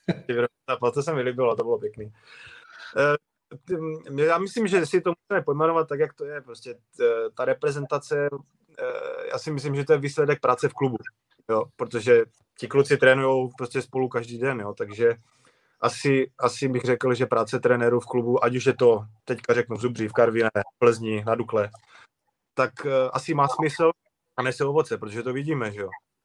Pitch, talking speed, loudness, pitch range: 135 Hz, 175 wpm, -24 LUFS, 120-165 Hz